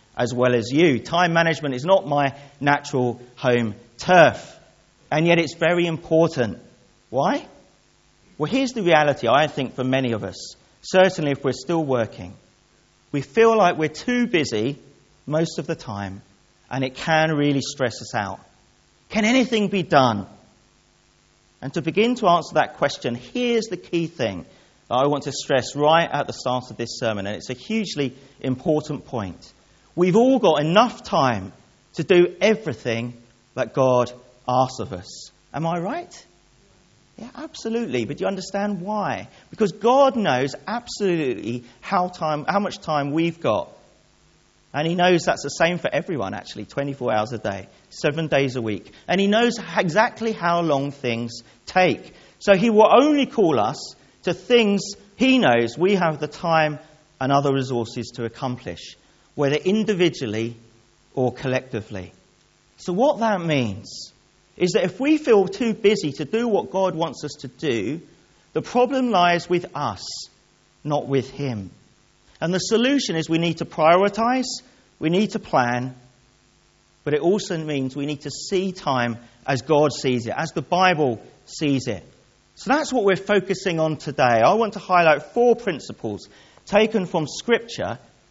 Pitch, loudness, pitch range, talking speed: 155 Hz, -21 LUFS, 130-195 Hz, 160 wpm